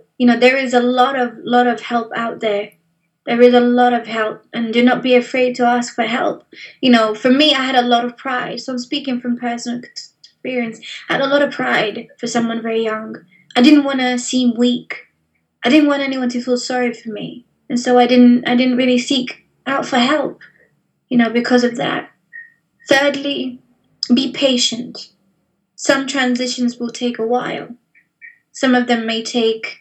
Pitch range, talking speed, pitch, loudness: 235-255 Hz, 195 wpm, 245 Hz, -16 LUFS